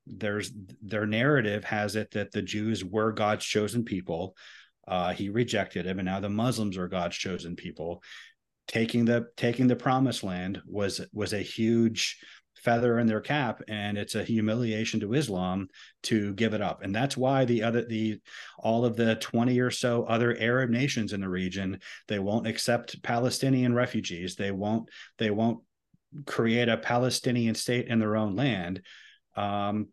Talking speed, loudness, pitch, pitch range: 170 wpm, -29 LUFS, 110 Hz, 100-120 Hz